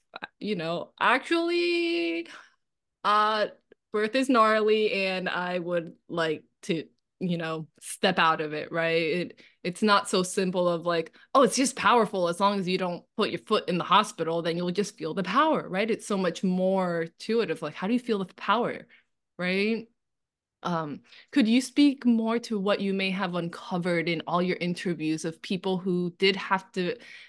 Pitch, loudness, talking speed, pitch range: 190 Hz, -27 LUFS, 185 wpm, 175-220 Hz